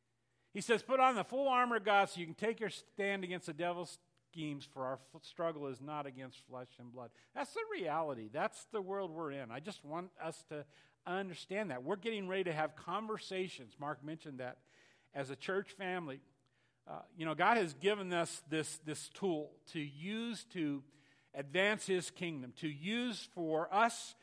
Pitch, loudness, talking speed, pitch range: 170 Hz, -39 LUFS, 190 wpm, 145-200 Hz